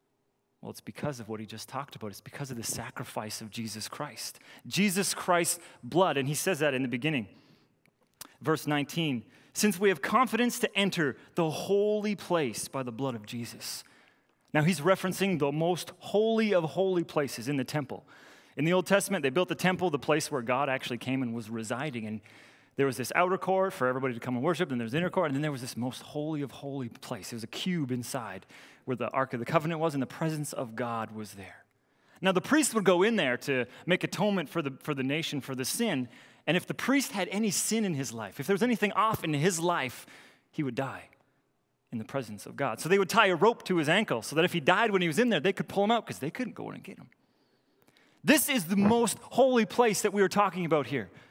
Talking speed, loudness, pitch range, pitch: 240 wpm, -29 LUFS, 130-190 Hz, 155 Hz